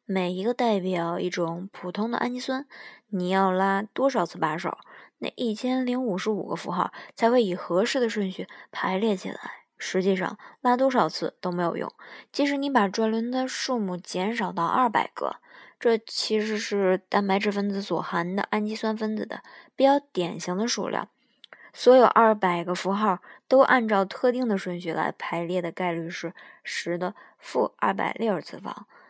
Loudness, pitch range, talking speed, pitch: -26 LUFS, 180-240 Hz, 260 characters per minute, 205 Hz